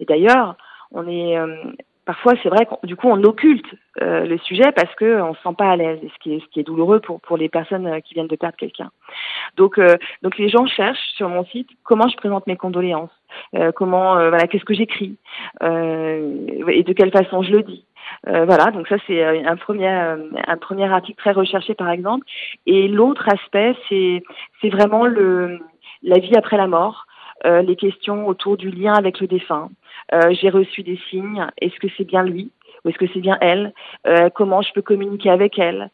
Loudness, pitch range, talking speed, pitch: -17 LUFS, 175-205 Hz, 210 wpm, 190 Hz